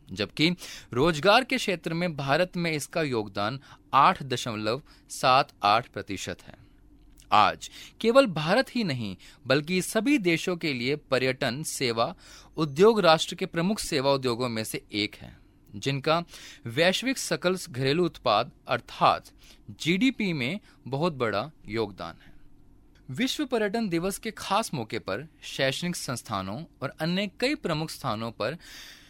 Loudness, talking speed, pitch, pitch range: -27 LUFS, 130 wpm, 155 Hz, 125-185 Hz